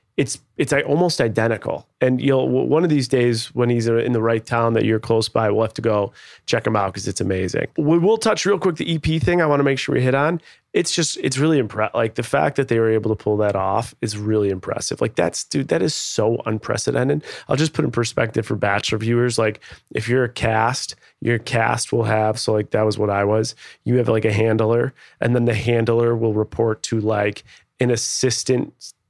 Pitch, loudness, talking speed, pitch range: 115 Hz, -20 LUFS, 225 wpm, 110-130 Hz